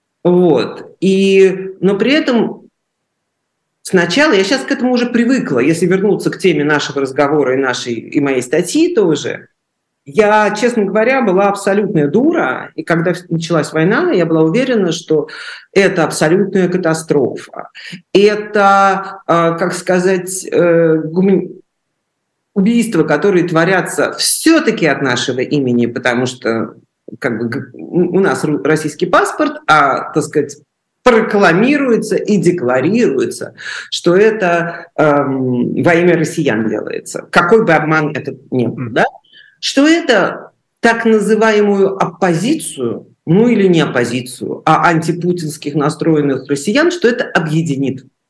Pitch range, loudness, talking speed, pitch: 155-210 Hz, -13 LUFS, 120 wpm, 180 Hz